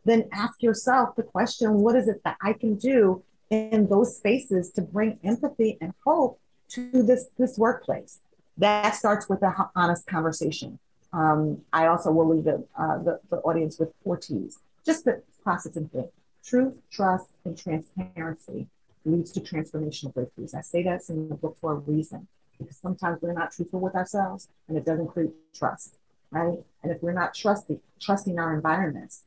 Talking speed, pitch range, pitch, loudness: 175 wpm, 160-220 Hz, 185 Hz, -26 LUFS